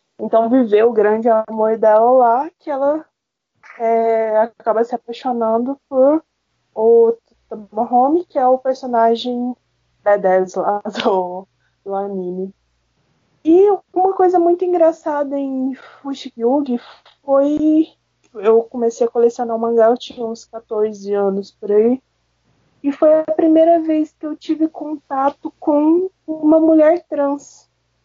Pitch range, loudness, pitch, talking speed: 225-305 Hz, -16 LUFS, 245 Hz, 130 wpm